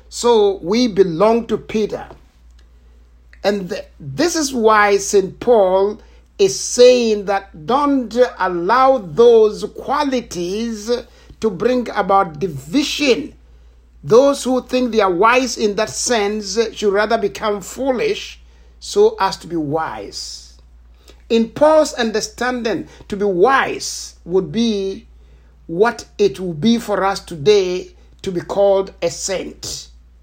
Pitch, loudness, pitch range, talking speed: 205 Hz, -17 LUFS, 175-240 Hz, 120 wpm